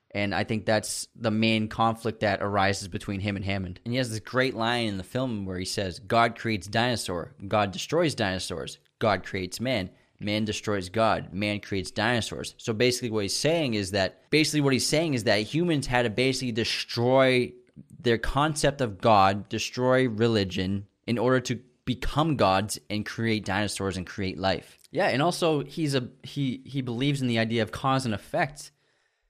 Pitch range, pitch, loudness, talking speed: 100-125 Hz, 110 Hz, -27 LUFS, 185 wpm